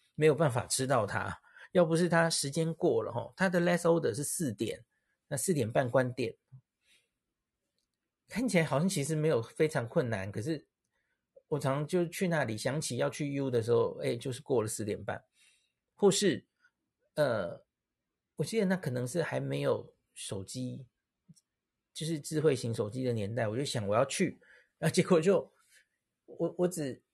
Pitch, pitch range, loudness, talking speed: 150 Hz, 125-170 Hz, -32 LUFS, 250 characters per minute